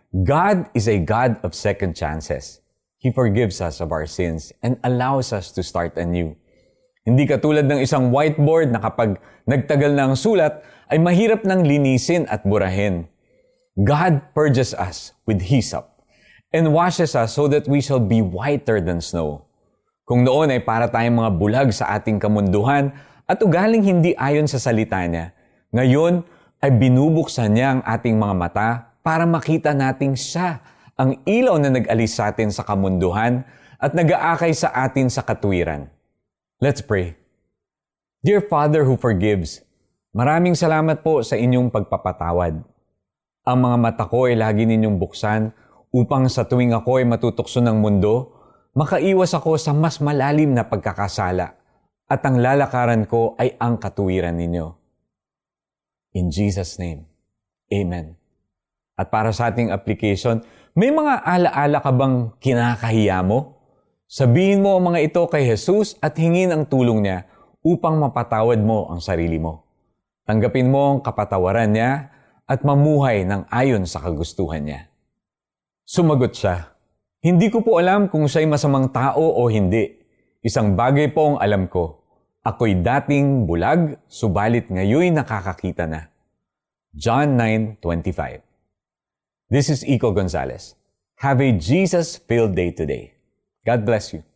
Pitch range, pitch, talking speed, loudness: 100-145 Hz, 120 Hz, 145 wpm, -19 LUFS